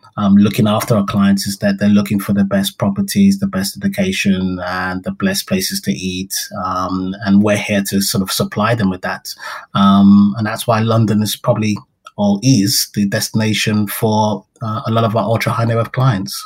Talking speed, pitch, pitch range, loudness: 200 wpm, 105 Hz, 100-115 Hz, -15 LUFS